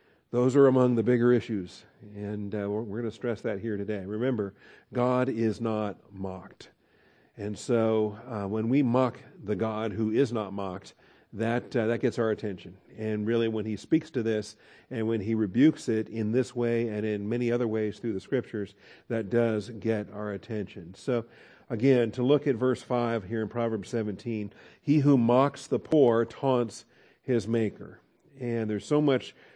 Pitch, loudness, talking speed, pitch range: 115 Hz, -28 LUFS, 185 wpm, 105-125 Hz